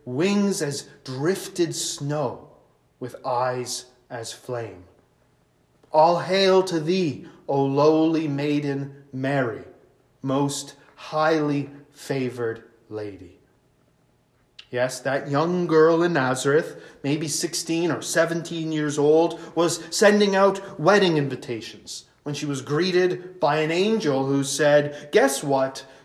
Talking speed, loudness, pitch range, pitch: 110 wpm, -23 LUFS, 135-165 Hz, 145 Hz